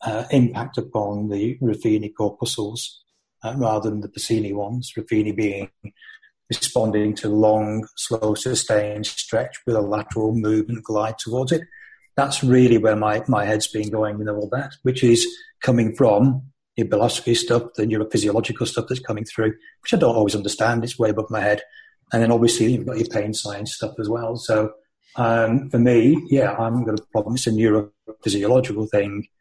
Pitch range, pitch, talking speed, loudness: 105-120 Hz, 110 Hz, 175 wpm, -21 LUFS